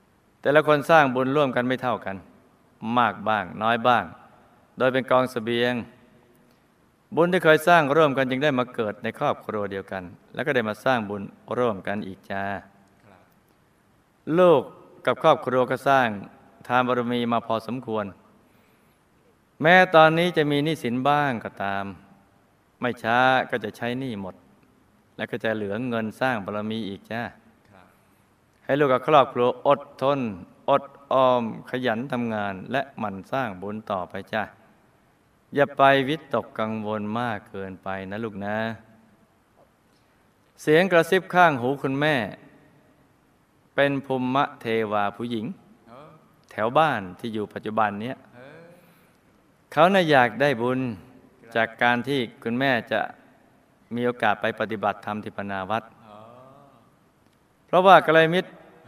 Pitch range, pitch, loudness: 105-135 Hz, 120 Hz, -23 LUFS